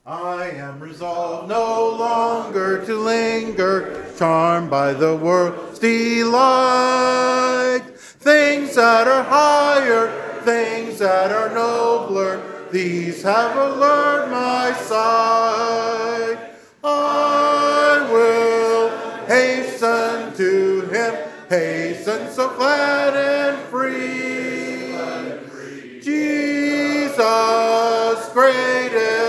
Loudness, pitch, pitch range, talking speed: -18 LUFS, 230 Hz, 220-260 Hz, 75 wpm